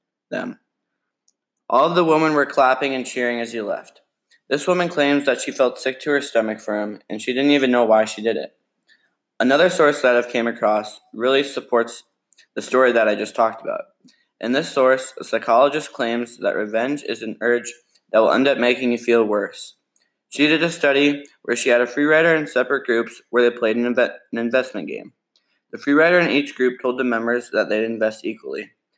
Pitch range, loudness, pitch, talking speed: 115-145 Hz, -19 LUFS, 125 Hz, 210 wpm